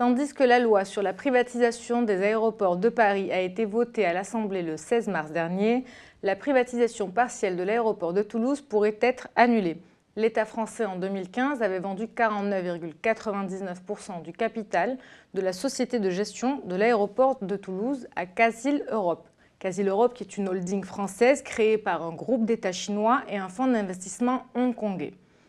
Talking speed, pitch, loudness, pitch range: 160 wpm, 215 Hz, -26 LUFS, 195-240 Hz